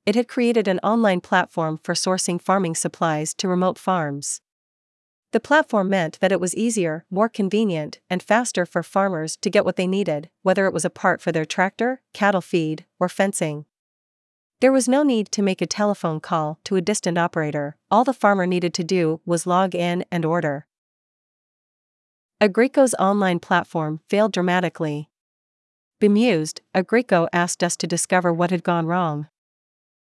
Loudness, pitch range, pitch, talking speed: -21 LUFS, 170-205 Hz, 180 Hz, 165 wpm